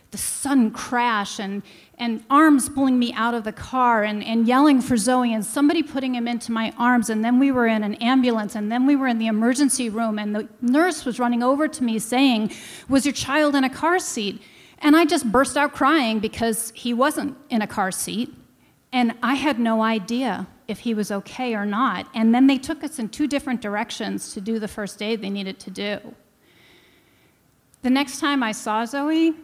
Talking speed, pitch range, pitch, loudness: 210 wpm, 220-275 Hz, 240 Hz, -21 LUFS